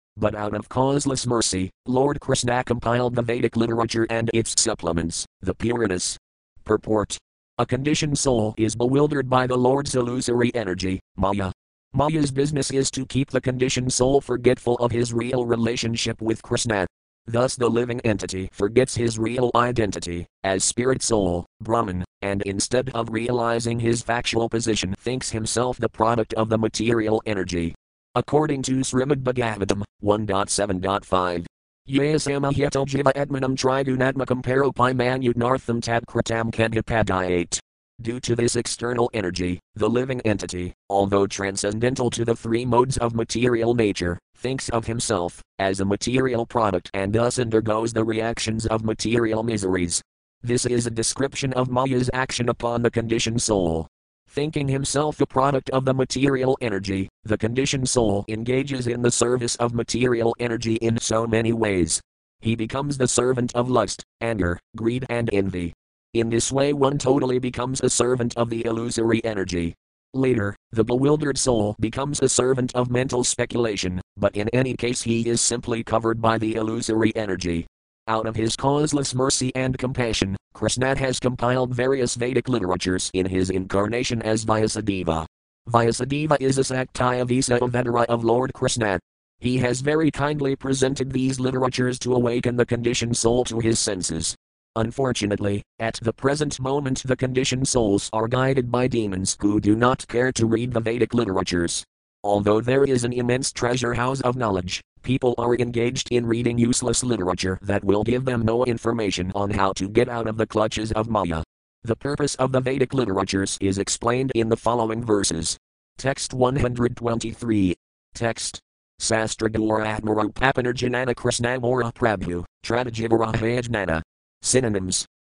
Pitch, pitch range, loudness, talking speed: 115 Hz, 105-125 Hz, -23 LUFS, 145 wpm